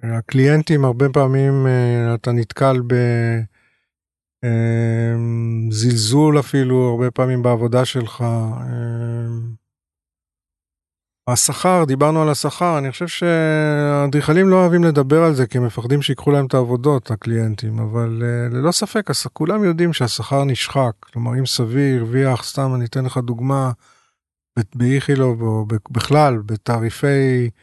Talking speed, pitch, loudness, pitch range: 115 wpm, 125 Hz, -17 LUFS, 115-140 Hz